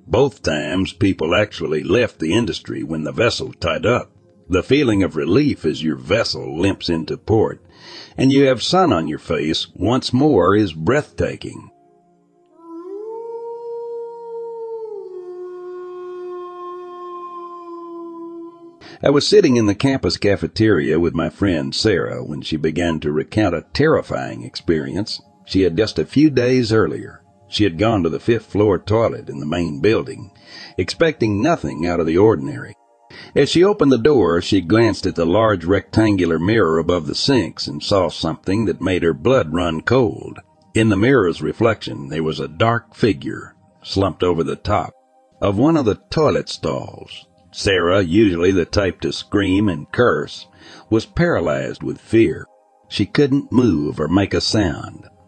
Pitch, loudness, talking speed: 110 Hz, -18 LUFS, 150 wpm